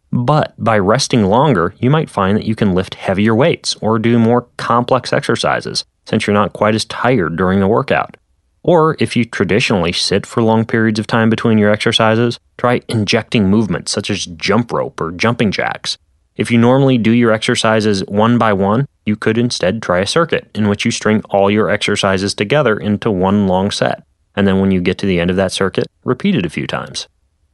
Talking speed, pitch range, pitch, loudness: 205 wpm, 100-115 Hz, 110 Hz, -14 LUFS